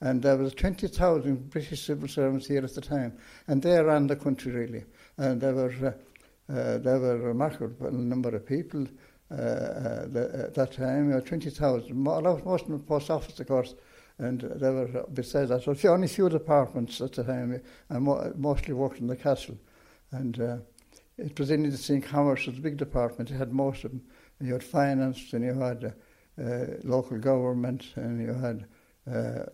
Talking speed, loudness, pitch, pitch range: 185 wpm, -29 LUFS, 135 Hz, 125-145 Hz